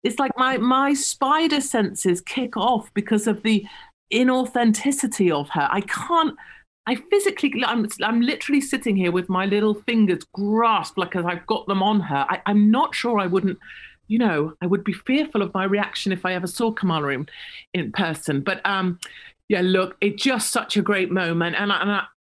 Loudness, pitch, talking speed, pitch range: -22 LUFS, 210 Hz, 195 wpm, 185-250 Hz